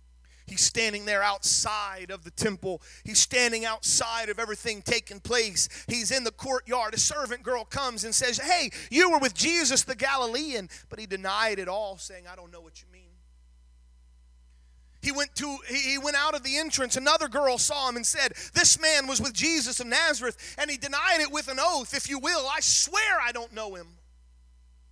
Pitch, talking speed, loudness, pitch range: 240 Hz, 195 wpm, -25 LUFS, 190-280 Hz